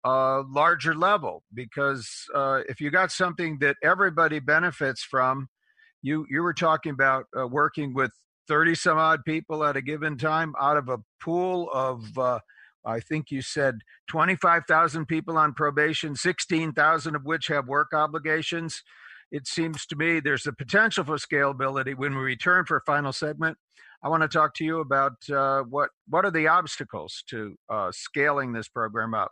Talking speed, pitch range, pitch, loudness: 180 wpm, 135-165 Hz, 150 Hz, -25 LUFS